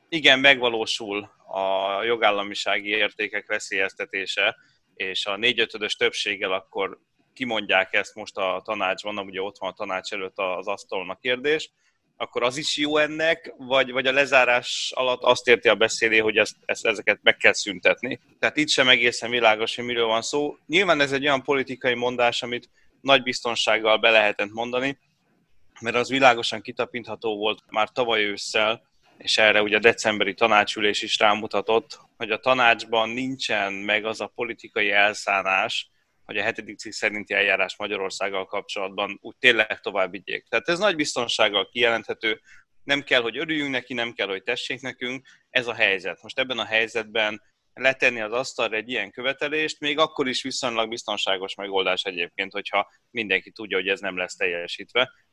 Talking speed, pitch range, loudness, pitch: 160 wpm, 105-135 Hz, -23 LUFS, 120 Hz